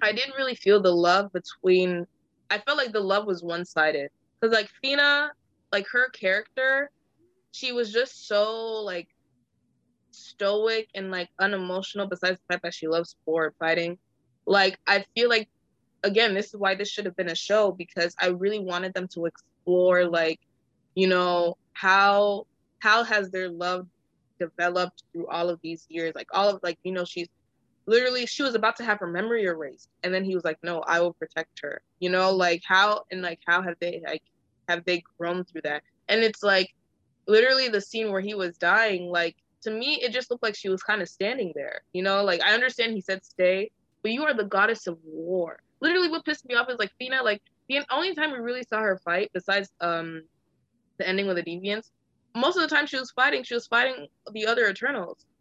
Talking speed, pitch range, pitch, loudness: 205 wpm, 175-225 Hz, 195 Hz, -25 LUFS